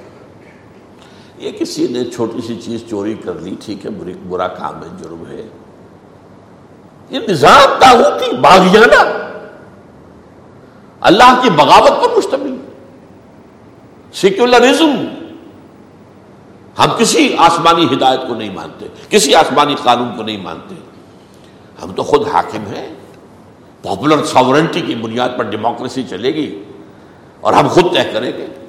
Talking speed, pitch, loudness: 125 wpm, 130 Hz, -11 LUFS